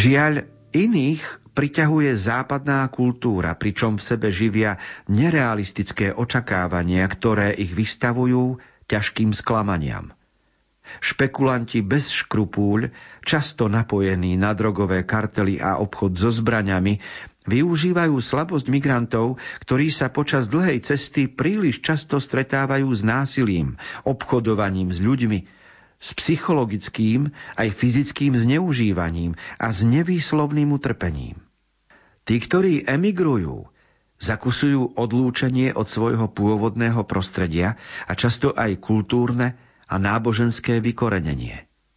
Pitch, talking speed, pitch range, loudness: 115 Hz, 100 wpm, 105-135 Hz, -21 LUFS